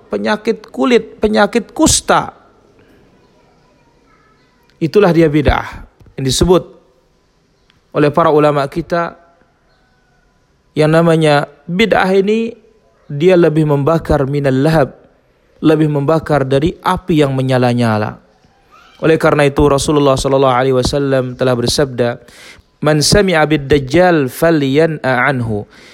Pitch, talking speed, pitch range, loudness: 155 Hz, 95 wpm, 135-170 Hz, -13 LUFS